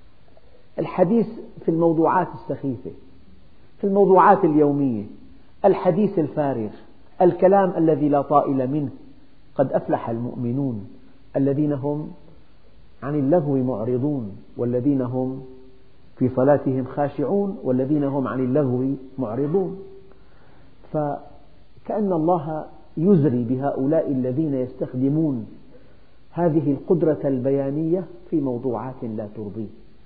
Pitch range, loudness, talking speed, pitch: 130-160 Hz, -22 LUFS, 90 wpm, 140 Hz